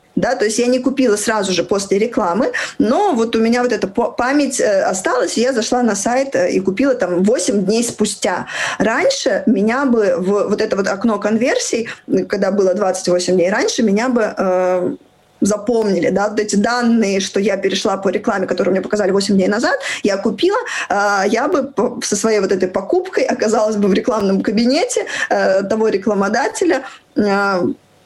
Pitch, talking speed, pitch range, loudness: 215 Hz, 175 wpm, 195-240 Hz, -16 LUFS